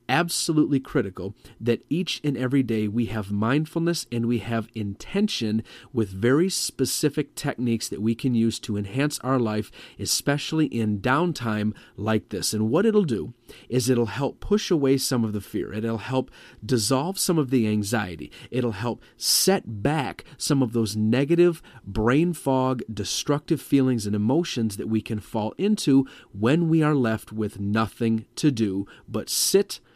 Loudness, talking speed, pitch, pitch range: -24 LUFS, 160 wpm, 120 Hz, 110-145 Hz